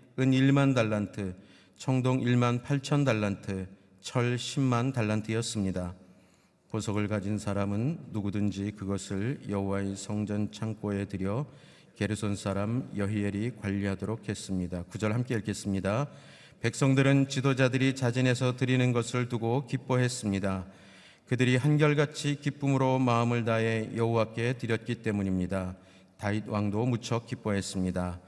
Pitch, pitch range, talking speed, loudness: 110 Hz, 100-130 Hz, 295 characters per minute, -30 LUFS